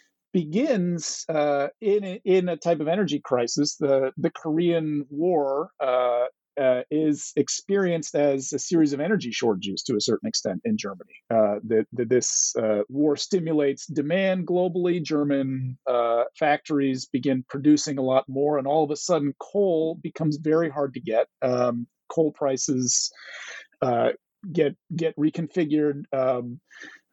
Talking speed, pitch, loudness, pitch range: 140 wpm, 150 Hz, -24 LUFS, 130-170 Hz